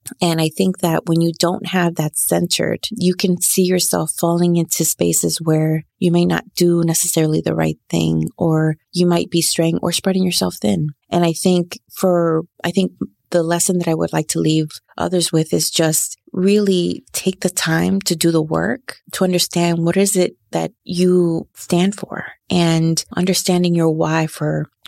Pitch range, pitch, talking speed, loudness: 160-180 Hz, 170 Hz, 180 wpm, -17 LUFS